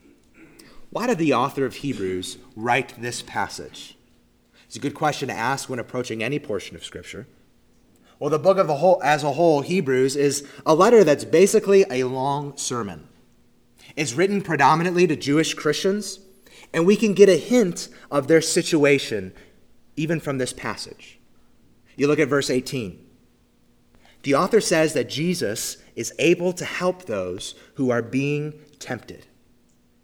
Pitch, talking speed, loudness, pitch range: 140 Hz, 155 wpm, -21 LUFS, 120-165 Hz